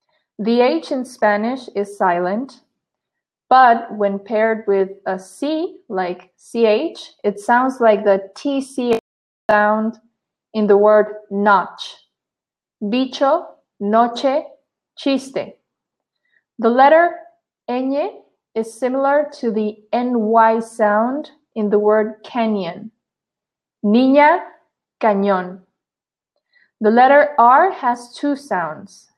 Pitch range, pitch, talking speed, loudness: 210-275 Hz, 230 Hz, 100 wpm, -17 LUFS